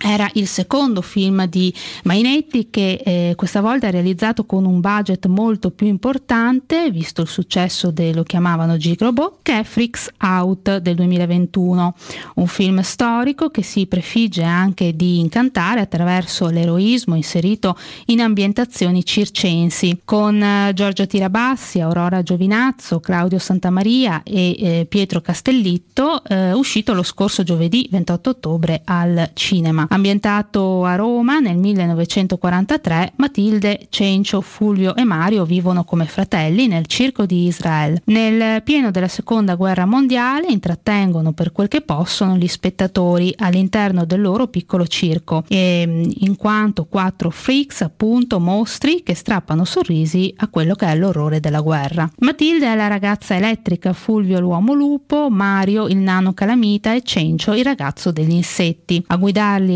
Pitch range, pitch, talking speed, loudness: 175-220 Hz, 190 Hz, 140 wpm, -17 LUFS